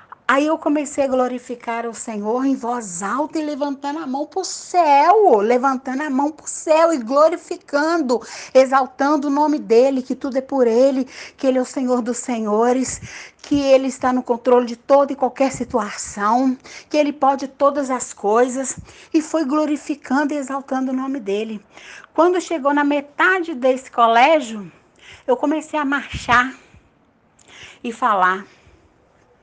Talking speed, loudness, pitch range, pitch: 155 wpm, -18 LUFS, 245-295 Hz, 270 Hz